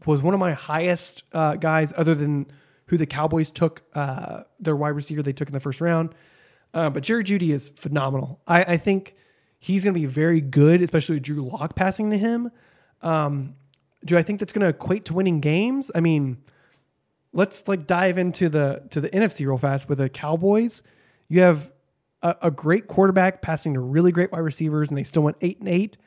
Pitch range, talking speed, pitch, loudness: 145-180 Hz, 205 wpm, 160 Hz, -22 LUFS